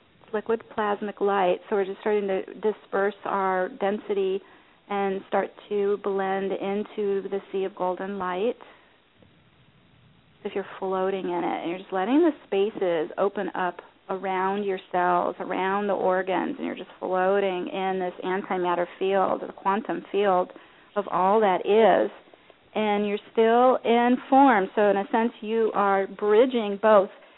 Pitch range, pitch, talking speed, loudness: 190-215 Hz, 200 Hz, 150 wpm, -25 LUFS